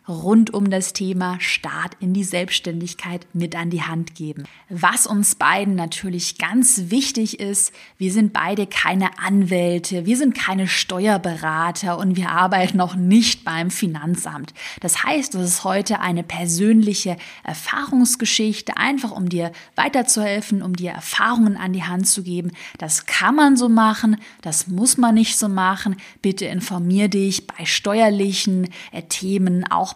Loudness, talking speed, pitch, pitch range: -19 LUFS, 150 wpm, 190 Hz, 180-215 Hz